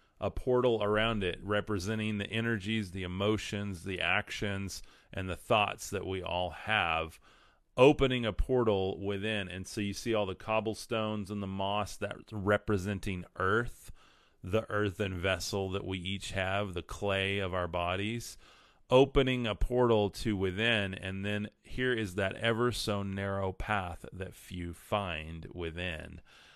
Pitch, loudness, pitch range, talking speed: 100 Hz, -32 LUFS, 95-110 Hz, 145 wpm